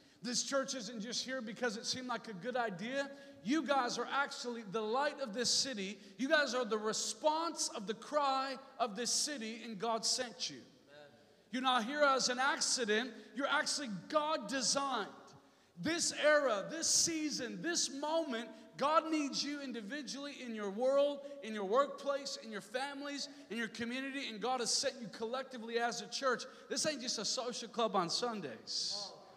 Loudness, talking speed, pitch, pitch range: -36 LUFS, 175 wpm, 255 Hz, 230-280 Hz